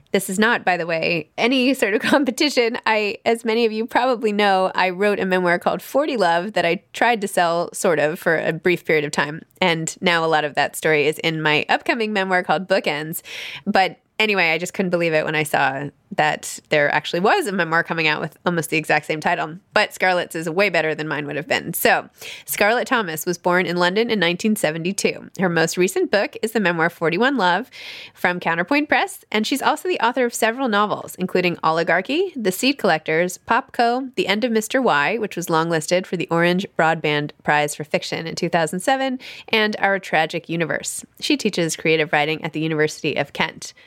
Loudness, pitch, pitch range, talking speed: -20 LUFS, 180 Hz, 165-220 Hz, 205 wpm